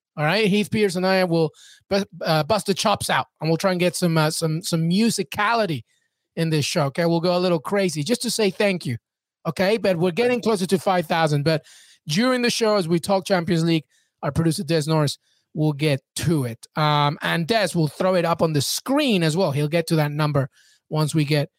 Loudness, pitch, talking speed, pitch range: -21 LUFS, 170 Hz, 220 wpm, 155-195 Hz